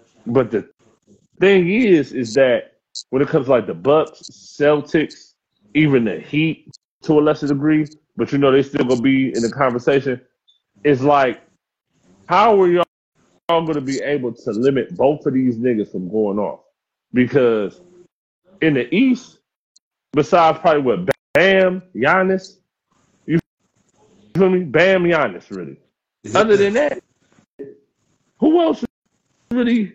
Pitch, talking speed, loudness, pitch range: 155 Hz, 140 wpm, -17 LUFS, 135-190 Hz